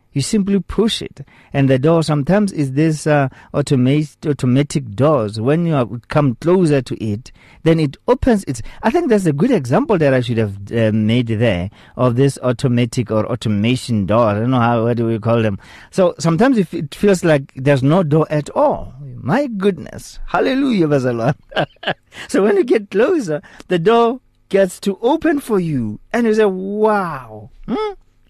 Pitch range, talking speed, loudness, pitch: 120-195 Hz, 170 wpm, -16 LUFS, 145 Hz